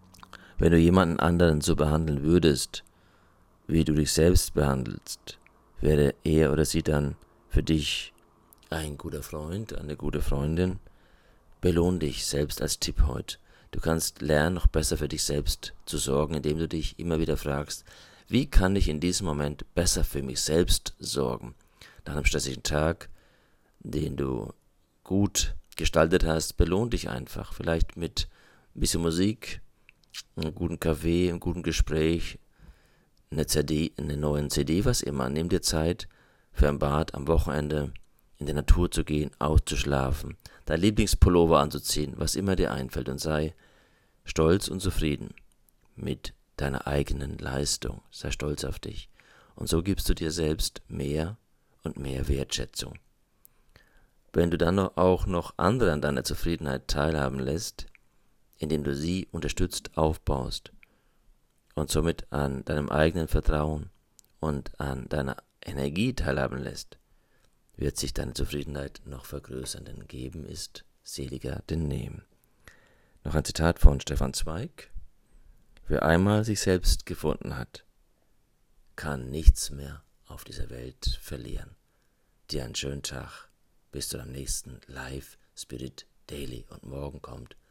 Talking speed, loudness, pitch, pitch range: 140 wpm, -28 LUFS, 75 Hz, 70-85 Hz